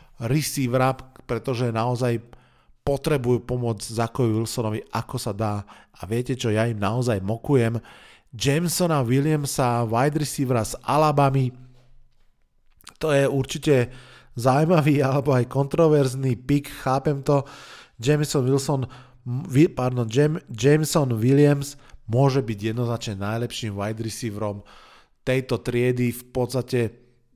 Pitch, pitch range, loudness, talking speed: 125 Hz, 115-140 Hz, -23 LUFS, 105 wpm